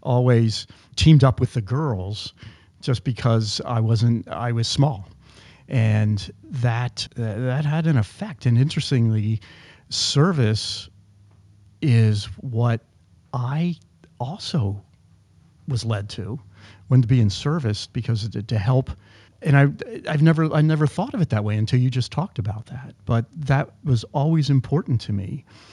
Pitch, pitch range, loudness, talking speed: 115 Hz, 105-135 Hz, -22 LUFS, 145 wpm